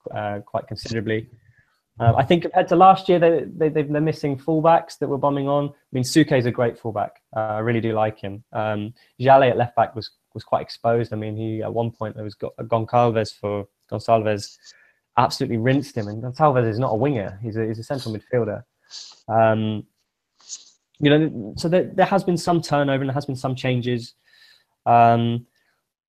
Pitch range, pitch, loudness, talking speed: 110-145 Hz, 120 Hz, -21 LUFS, 195 wpm